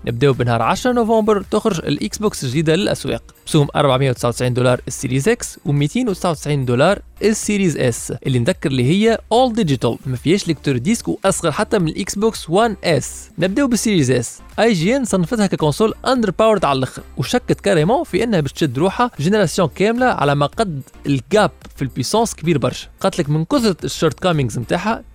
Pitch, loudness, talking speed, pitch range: 175 Hz, -17 LUFS, 170 wpm, 140-215 Hz